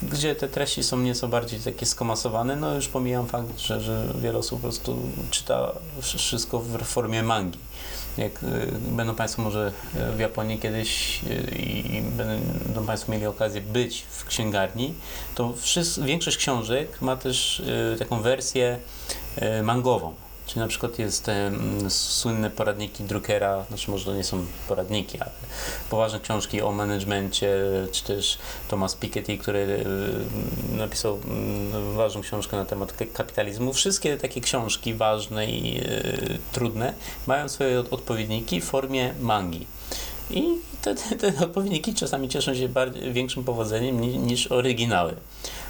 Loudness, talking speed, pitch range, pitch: -26 LUFS, 140 wpm, 105-125 Hz, 115 Hz